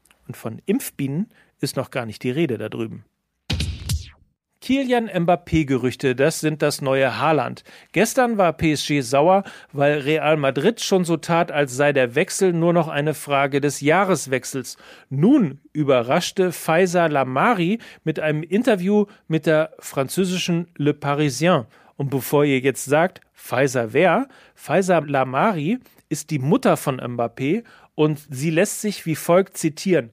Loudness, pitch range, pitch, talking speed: -21 LUFS, 135-185 Hz, 155 Hz, 140 wpm